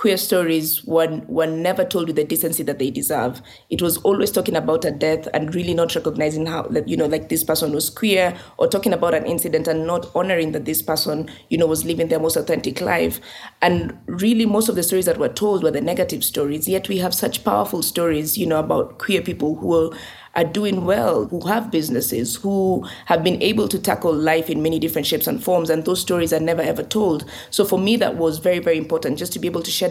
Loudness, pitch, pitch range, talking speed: -20 LUFS, 165 Hz, 160-185 Hz, 235 wpm